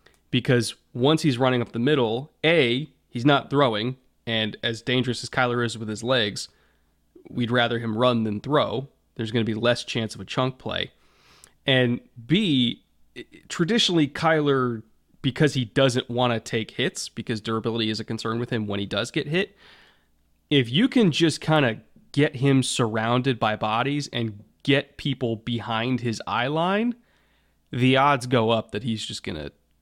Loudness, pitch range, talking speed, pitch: -24 LUFS, 110-140 Hz, 175 wpm, 125 Hz